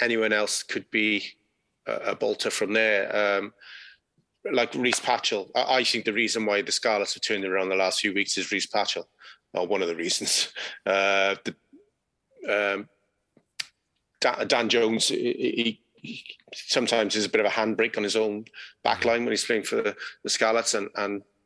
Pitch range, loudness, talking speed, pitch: 100-110 Hz, -25 LUFS, 185 wpm, 105 Hz